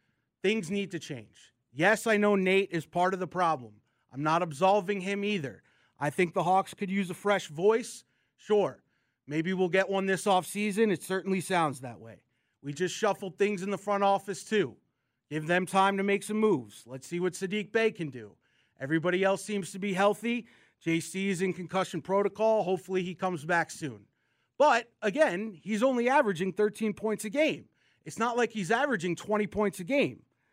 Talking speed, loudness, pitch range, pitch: 190 wpm, -29 LUFS, 170-205 Hz, 190 Hz